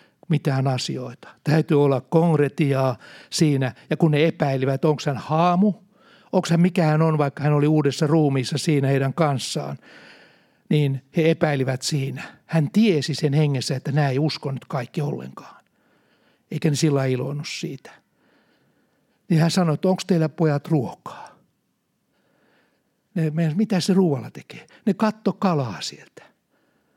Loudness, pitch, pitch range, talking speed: -22 LUFS, 155 Hz, 140-170 Hz, 135 wpm